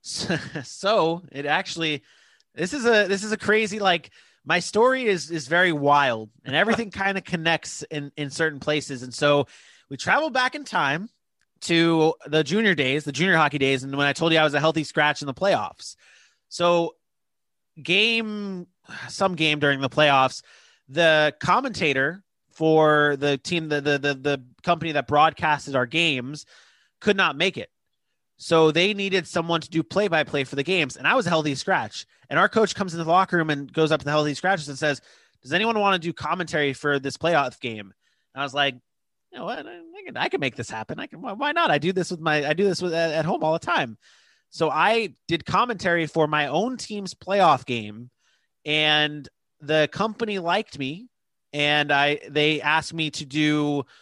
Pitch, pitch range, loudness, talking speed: 160 Hz, 145-185 Hz, -22 LUFS, 200 wpm